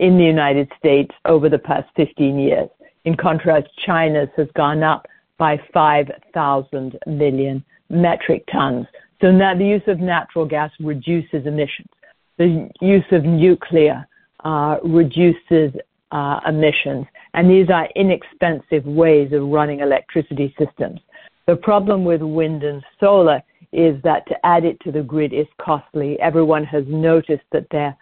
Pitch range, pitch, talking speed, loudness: 145-170 Hz, 155 Hz, 145 wpm, -17 LUFS